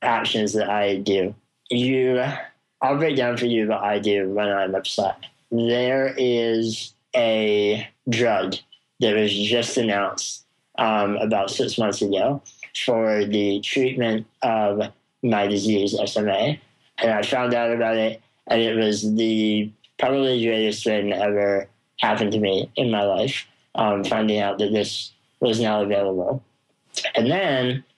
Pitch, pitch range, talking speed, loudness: 110 Hz, 105-120 Hz, 145 wpm, -22 LUFS